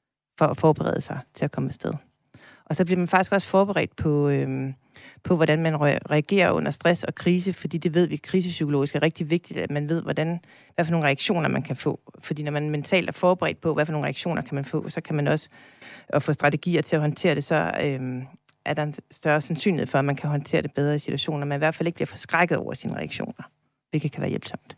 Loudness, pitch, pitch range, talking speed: -25 LUFS, 155 Hz, 145-170 Hz, 240 wpm